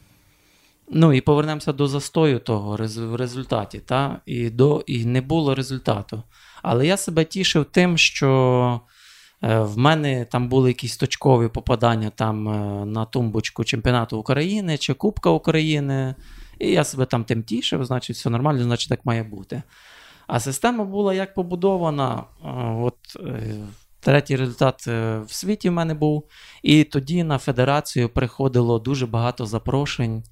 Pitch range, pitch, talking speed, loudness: 115-150 Hz, 130 Hz, 150 wpm, -21 LUFS